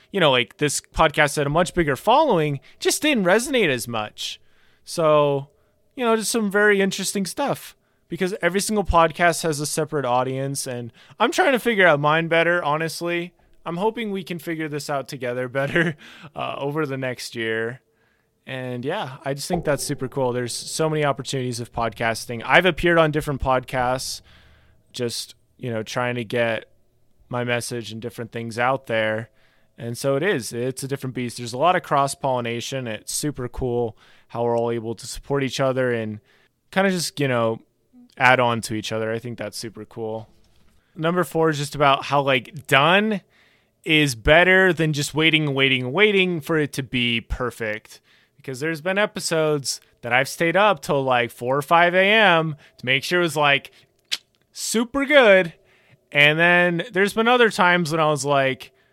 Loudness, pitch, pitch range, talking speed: -21 LUFS, 140 Hz, 125-170 Hz, 180 wpm